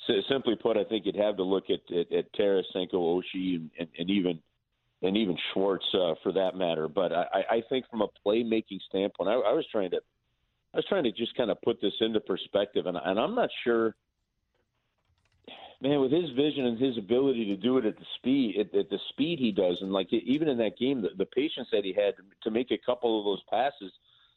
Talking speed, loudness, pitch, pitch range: 220 wpm, -29 LUFS, 115 Hz, 95-145 Hz